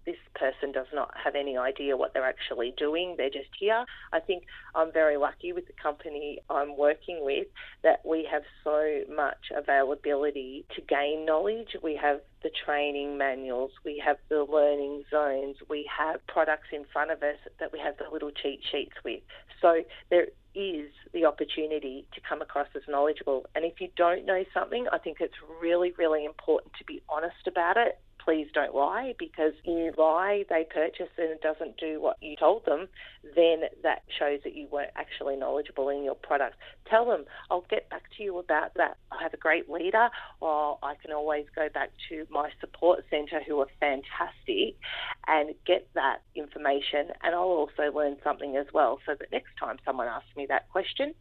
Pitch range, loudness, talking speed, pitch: 145-170 Hz, -29 LUFS, 190 wpm, 155 Hz